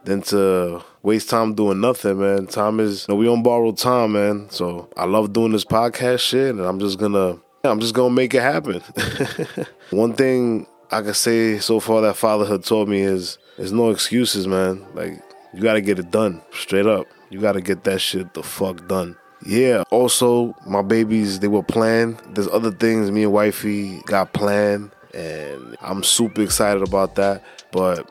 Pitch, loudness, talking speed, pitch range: 105 Hz, -19 LUFS, 190 wpm, 100-115 Hz